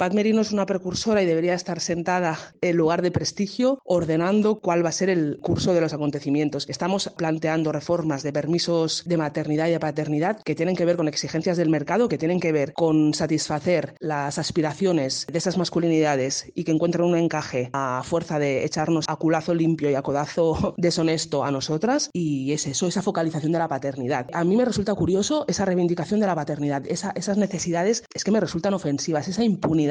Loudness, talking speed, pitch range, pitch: -23 LUFS, 195 wpm, 155-180 Hz, 165 Hz